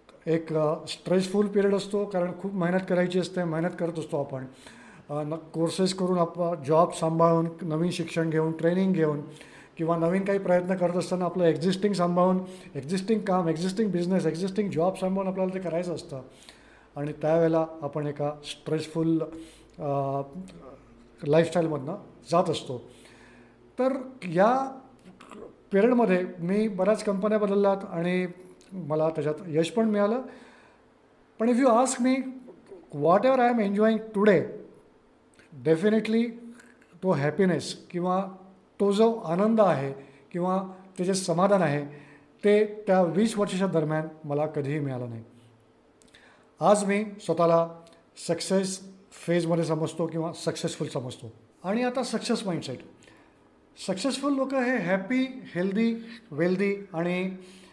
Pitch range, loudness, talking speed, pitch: 160-200 Hz, -26 LUFS, 125 wpm, 175 Hz